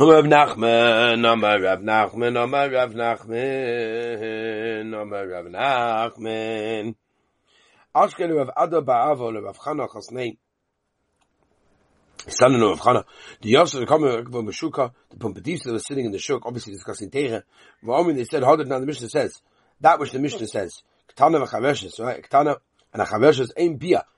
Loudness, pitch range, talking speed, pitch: -21 LUFS, 110-130 Hz, 160 wpm, 115 Hz